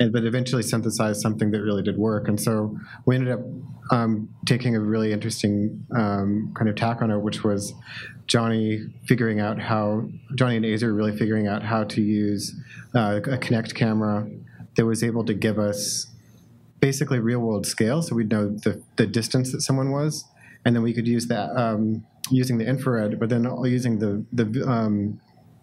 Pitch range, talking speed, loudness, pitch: 105-125 Hz, 180 wpm, -24 LUFS, 115 Hz